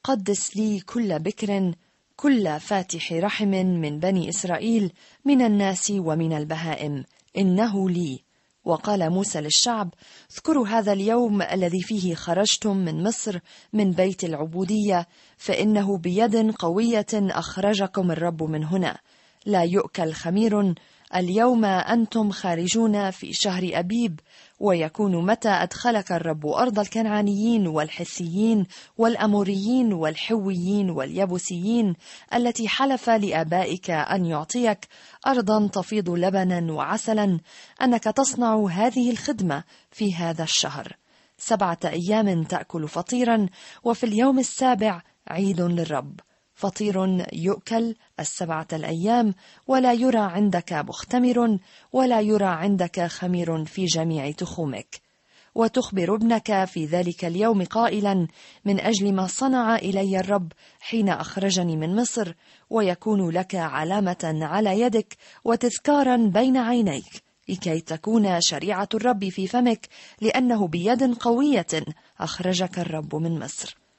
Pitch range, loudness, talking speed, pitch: 175-225 Hz, -23 LUFS, 110 wpm, 195 Hz